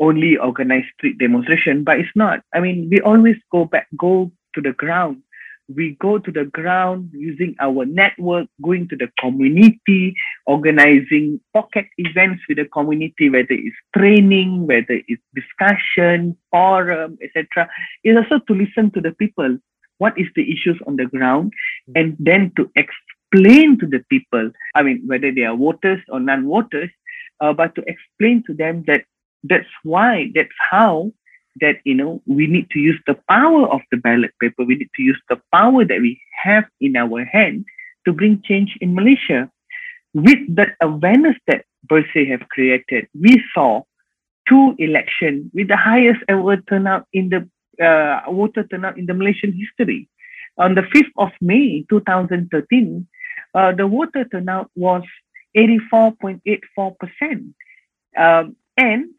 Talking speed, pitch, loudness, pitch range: 160 wpm, 185 Hz, -15 LUFS, 155-220 Hz